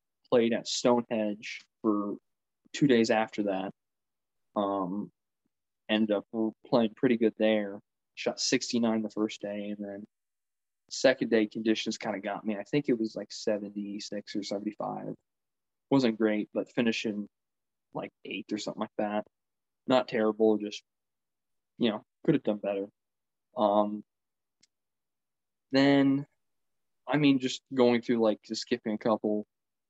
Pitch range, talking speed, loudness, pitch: 105-115 Hz, 135 wpm, -30 LUFS, 110 Hz